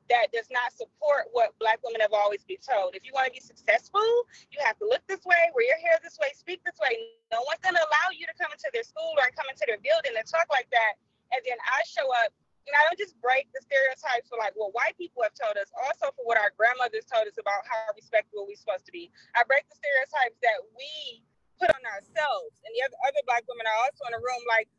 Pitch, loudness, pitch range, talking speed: 275 Hz, -27 LUFS, 235-330 Hz, 260 wpm